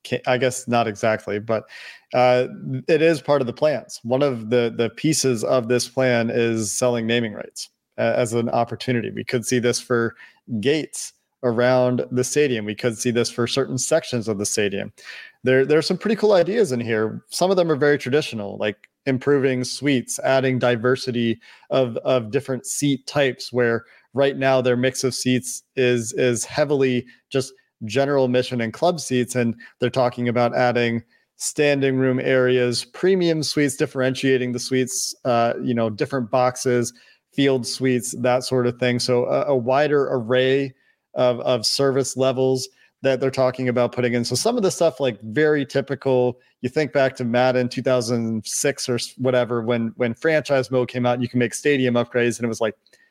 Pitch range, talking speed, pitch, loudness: 120-135 Hz, 180 wpm, 125 Hz, -21 LUFS